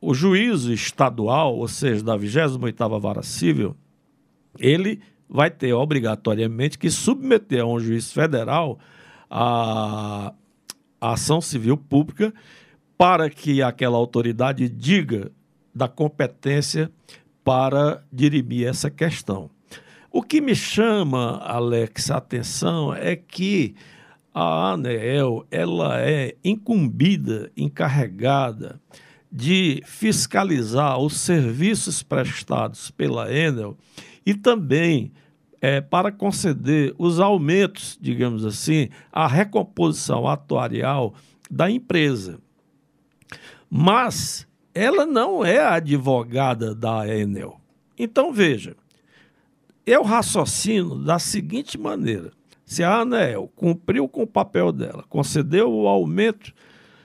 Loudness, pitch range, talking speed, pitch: -21 LUFS, 120-175 Hz, 100 wpm, 140 Hz